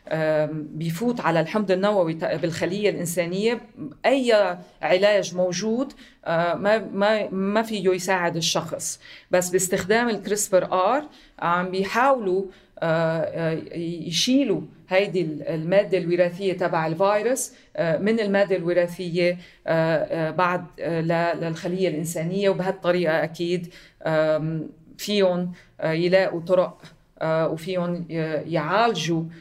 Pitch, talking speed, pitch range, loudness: 180 Hz, 80 wpm, 165-200 Hz, -23 LUFS